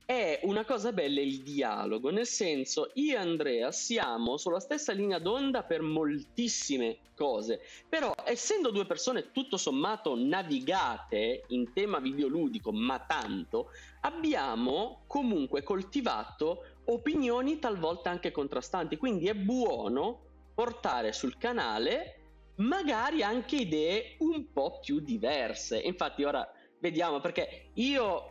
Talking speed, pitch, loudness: 120 wpm, 235 Hz, -32 LUFS